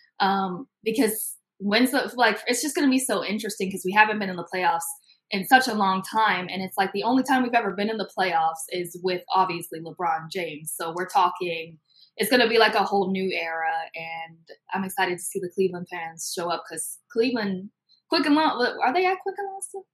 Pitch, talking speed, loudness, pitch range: 195 Hz, 225 wpm, -24 LUFS, 175-230 Hz